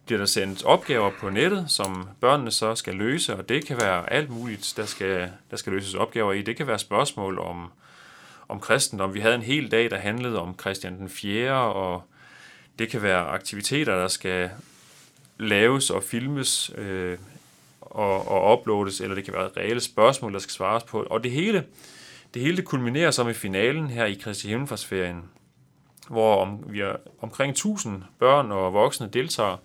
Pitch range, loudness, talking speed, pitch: 95-120 Hz, -25 LUFS, 180 wpm, 105 Hz